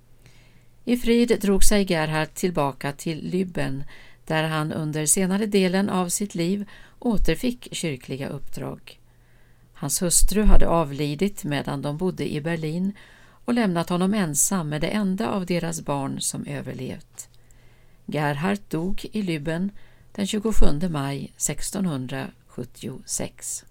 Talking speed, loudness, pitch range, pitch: 120 wpm, -25 LUFS, 145-195 Hz, 170 Hz